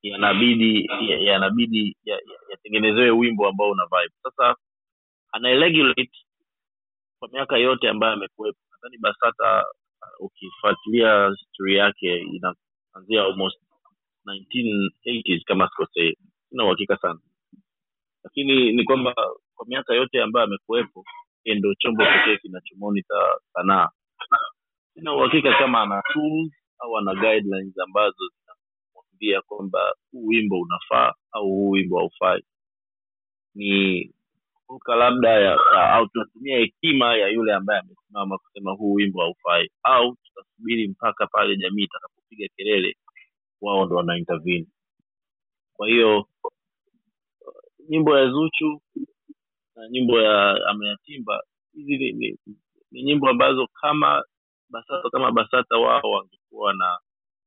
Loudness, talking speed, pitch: -21 LUFS, 115 wpm, 115 Hz